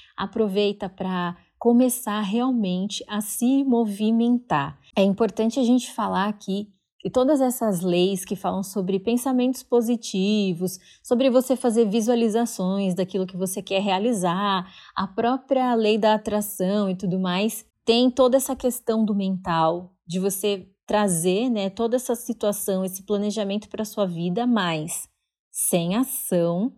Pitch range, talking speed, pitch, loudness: 190-235 Hz, 135 wpm, 210 Hz, -23 LUFS